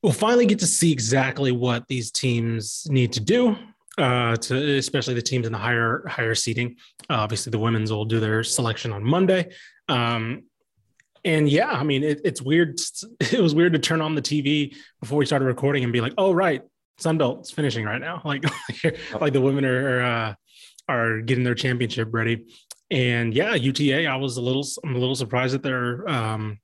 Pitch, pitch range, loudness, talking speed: 130 Hz, 120-150 Hz, -23 LUFS, 195 wpm